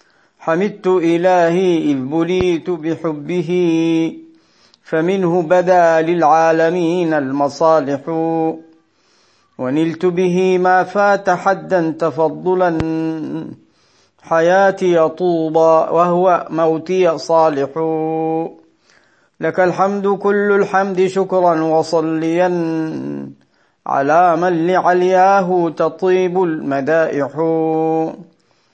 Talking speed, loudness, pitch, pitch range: 65 wpm, -15 LUFS, 165 Hz, 160-185 Hz